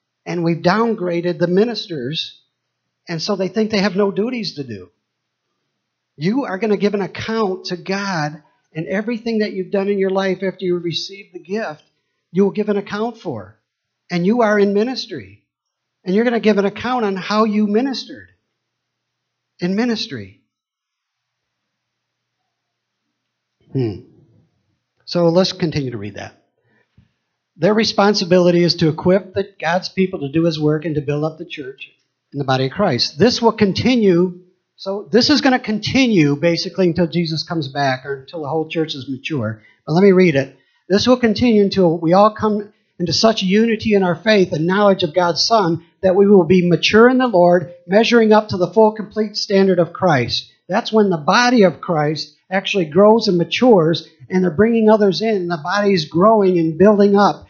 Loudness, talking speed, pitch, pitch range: -16 LUFS, 180 wpm, 185 Hz, 160-210 Hz